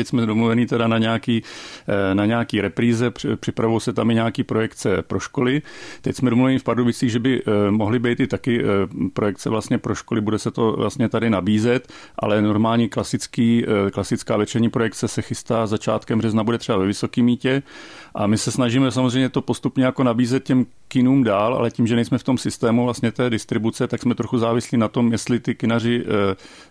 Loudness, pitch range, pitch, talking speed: -20 LUFS, 110-125 Hz, 115 Hz, 190 wpm